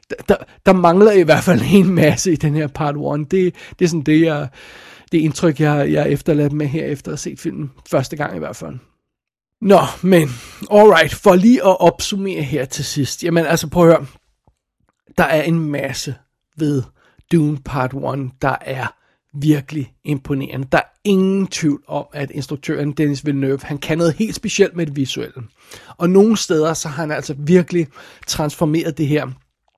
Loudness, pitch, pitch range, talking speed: -16 LUFS, 155 Hz, 145-170 Hz, 185 wpm